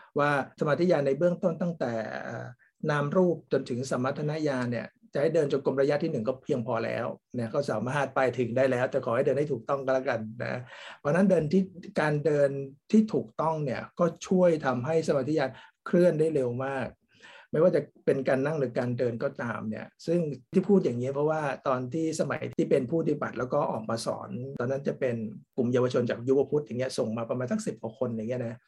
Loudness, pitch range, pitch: -28 LUFS, 125-160 Hz, 140 Hz